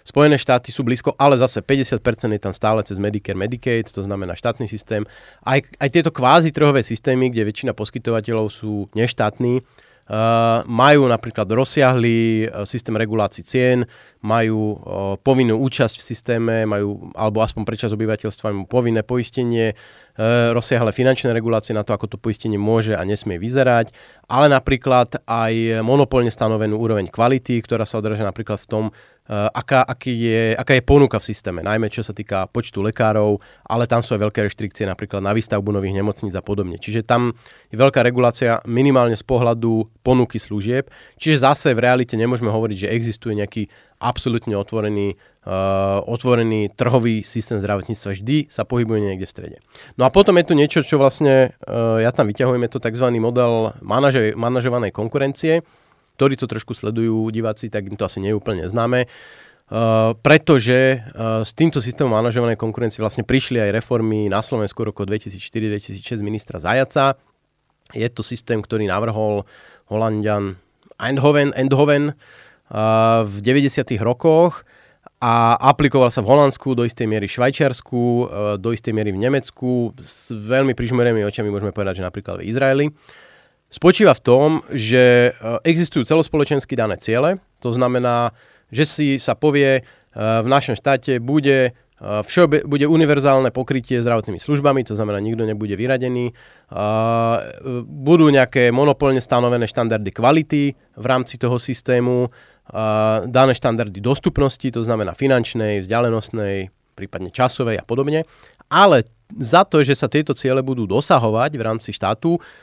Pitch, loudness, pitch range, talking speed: 115 Hz, -18 LUFS, 110-130 Hz, 150 wpm